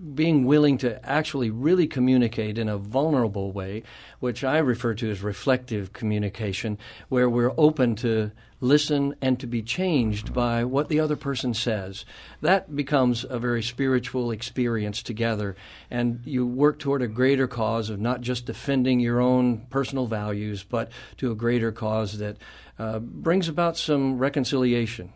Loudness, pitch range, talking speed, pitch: -25 LUFS, 110-135 Hz, 155 wpm, 120 Hz